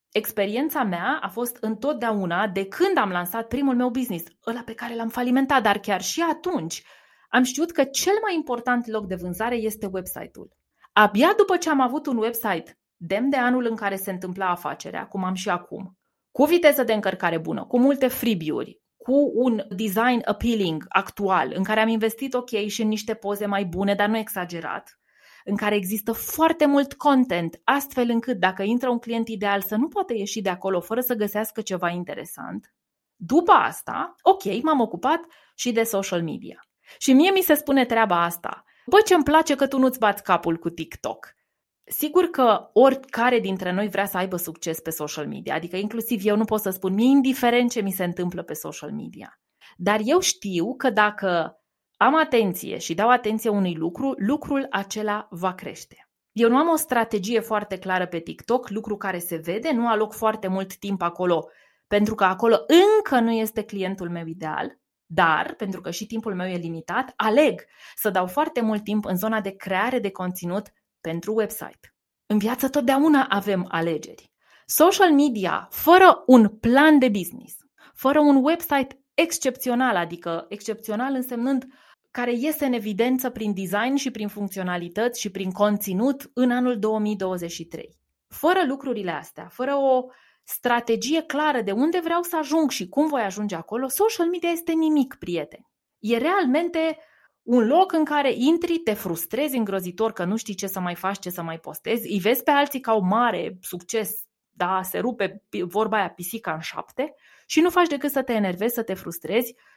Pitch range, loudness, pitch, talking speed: 195-265 Hz, -23 LUFS, 225 Hz, 180 wpm